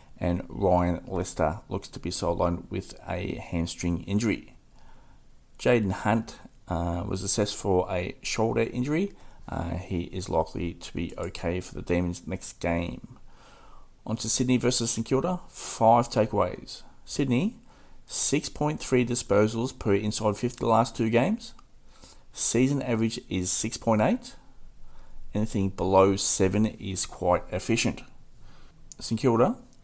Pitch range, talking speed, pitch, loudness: 90-115 Hz, 125 wpm, 105 Hz, -27 LUFS